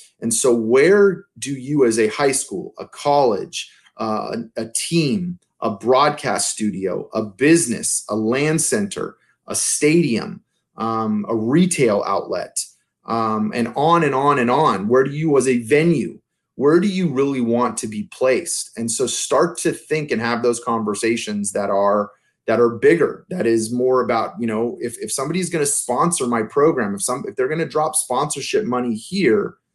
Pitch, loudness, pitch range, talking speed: 125 Hz, -19 LUFS, 115-155 Hz, 175 wpm